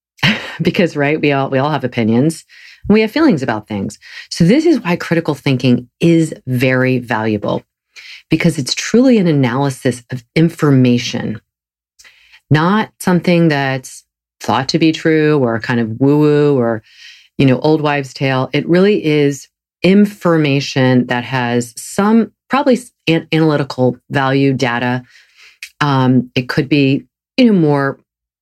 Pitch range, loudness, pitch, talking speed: 125-165 Hz, -14 LUFS, 140 Hz, 135 wpm